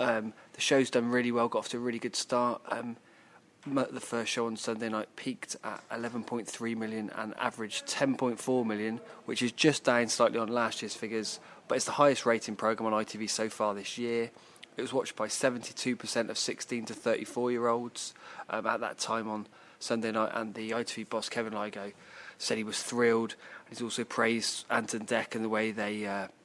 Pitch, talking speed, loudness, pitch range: 115 Hz, 195 wpm, -32 LUFS, 110-120 Hz